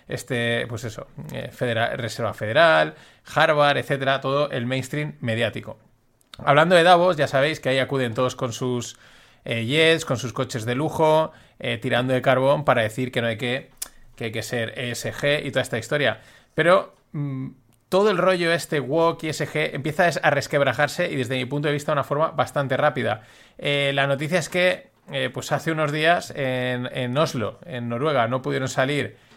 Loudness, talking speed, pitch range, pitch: -22 LUFS, 185 wpm, 125-150 Hz, 135 Hz